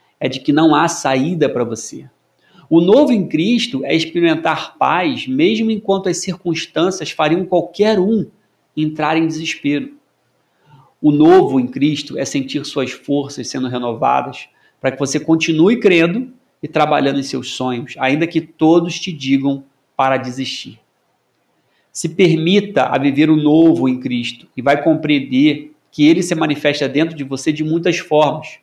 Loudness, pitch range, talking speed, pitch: -16 LUFS, 140-175 Hz, 155 wpm, 155 Hz